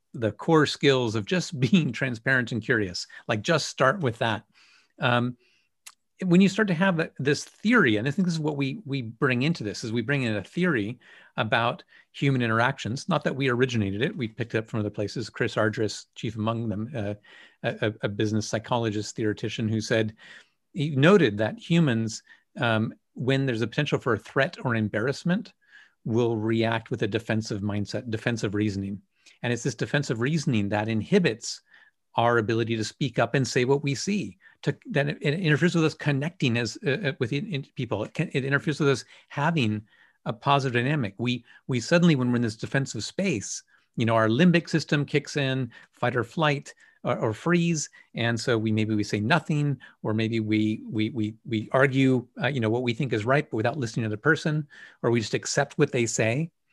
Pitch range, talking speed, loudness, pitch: 110-145 Hz, 195 wpm, -26 LUFS, 125 Hz